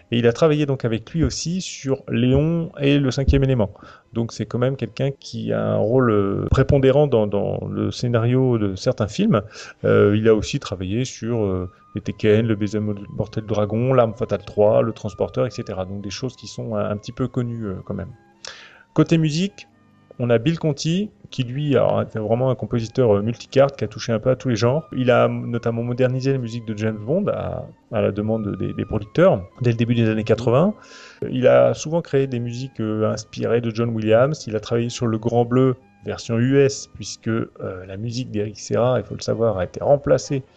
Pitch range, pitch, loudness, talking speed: 105-130 Hz, 120 Hz, -21 LUFS, 210 wpm